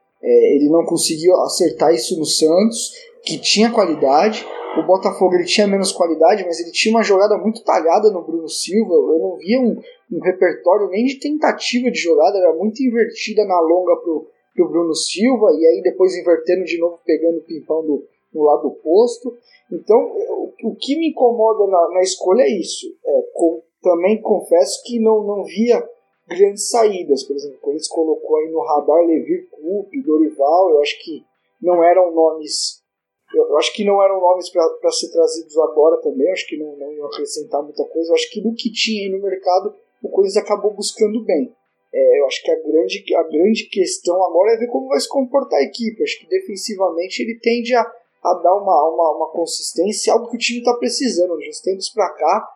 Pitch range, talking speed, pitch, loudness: 170-280 Hz, 195 wpm, 210 Hz, -17 LUFS